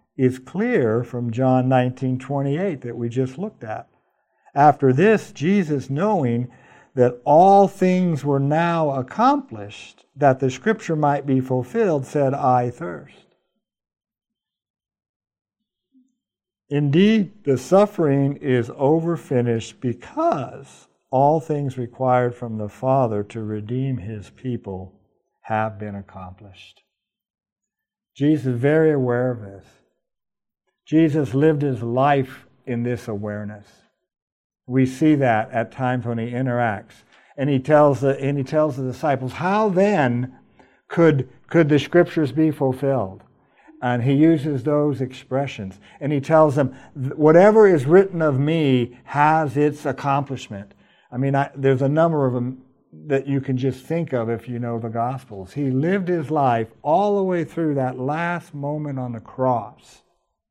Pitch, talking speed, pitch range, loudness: 135 Hz, 135 wpm, 120-155 Hz, -20 LUFS